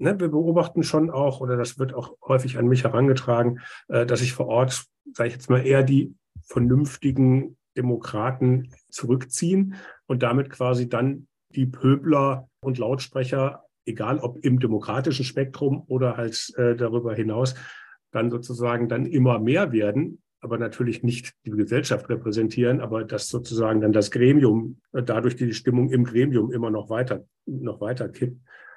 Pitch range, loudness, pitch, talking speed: 120-135 Hz, -23 LUFS, 125 Hz, 150 wpm